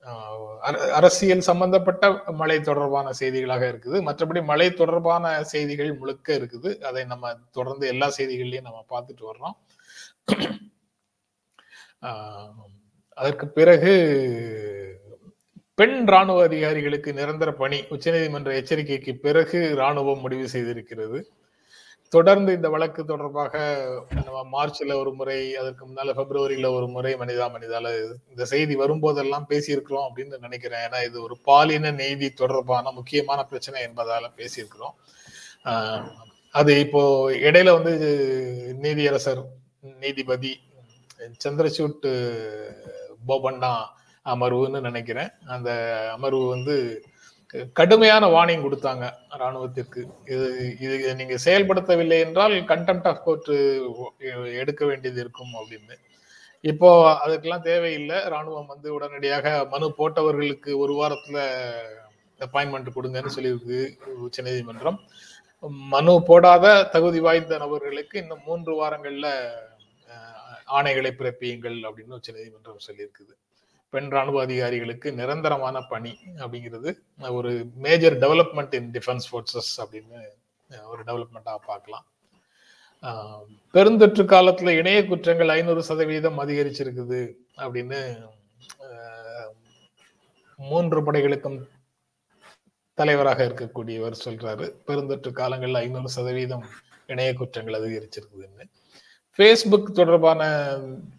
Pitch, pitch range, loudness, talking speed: 135 Hz, 125-155 Hz, -21 LUFS, 95 wpm